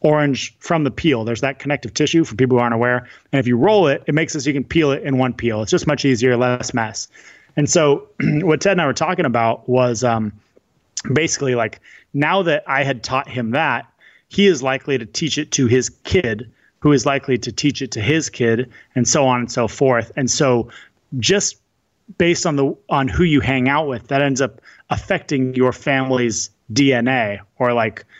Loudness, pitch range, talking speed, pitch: -18 LUFS, 120-150 Hz, 215 wpm, 135 Hz